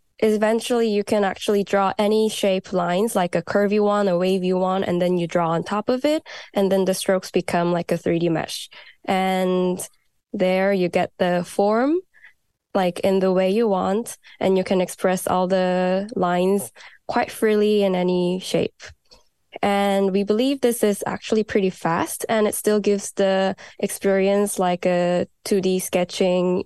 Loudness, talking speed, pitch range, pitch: -21 LUFS, 165 wpm, 185-210 Hz, 190 Hz